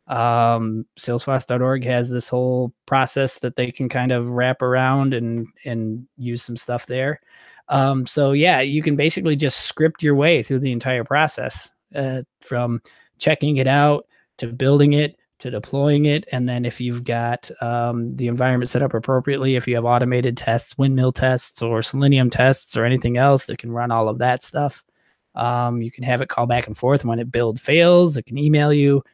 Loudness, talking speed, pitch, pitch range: -19 LUFS, 190 wpm, 125 Hz, 120-140 Hz